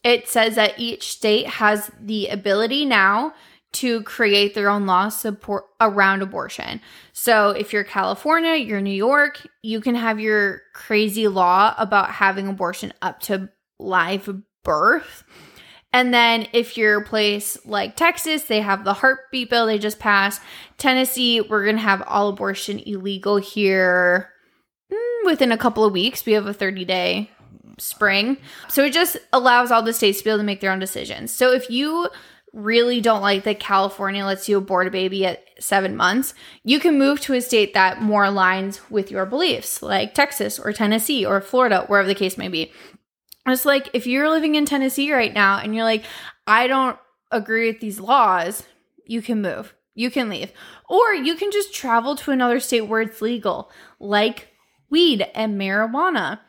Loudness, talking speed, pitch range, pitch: -19 LUFS, 175 wpm, 200-255 Hz, 215 Hz